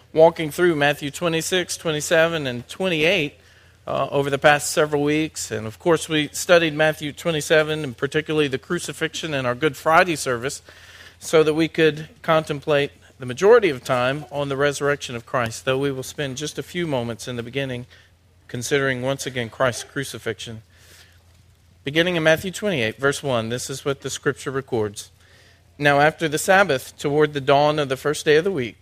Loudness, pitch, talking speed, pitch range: -21 LUFS, 140 Hz, 175 wpm, 120-155 Hz